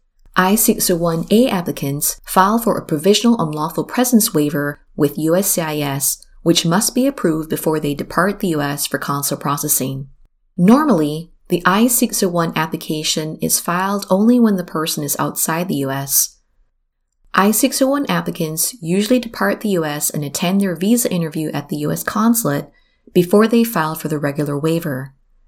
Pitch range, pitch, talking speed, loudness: 145-200 Hz, 165 Hz, 140 wpm, -17 LUFS